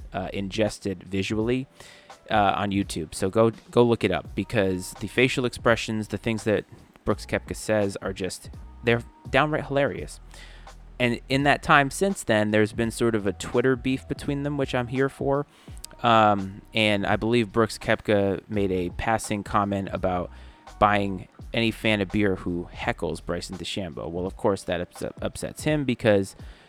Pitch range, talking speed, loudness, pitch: 95-120 Hz, 165 wpm, -25 LUFS, 105 Hz